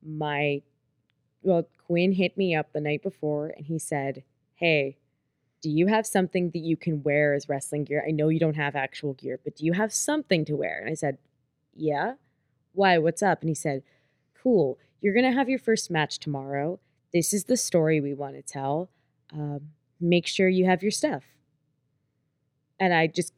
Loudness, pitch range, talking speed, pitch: -26 LUFS, 145-175 Hz, 195 wpm, 155 Hz